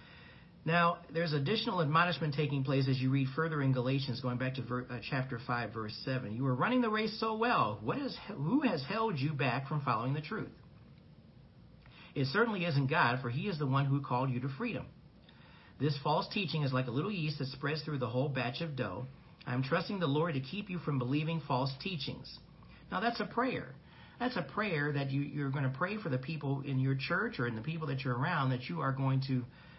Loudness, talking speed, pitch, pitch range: -34 LUFS, 225 wpm, 140 Hz, 130-170 Hz